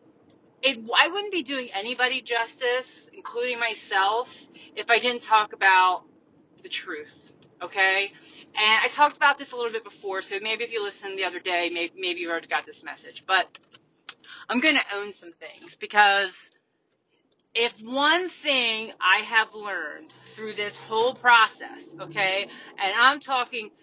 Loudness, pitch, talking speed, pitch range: -23 LUFS, 220 Hz, 160 wpm, 195-255 Hz